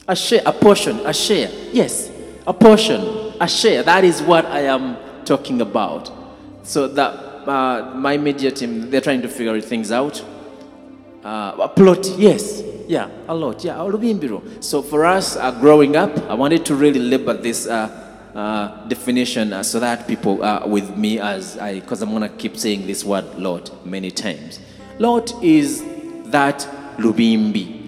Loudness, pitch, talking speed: -17 LUFS, 140 Hz, 170 wpm